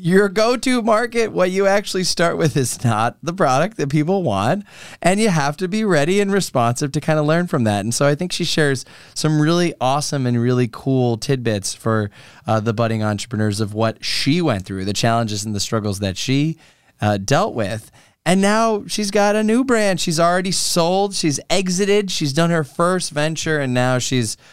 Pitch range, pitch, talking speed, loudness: 115-185 Hz, 150 Hz, 205 wpm, -18 LUFS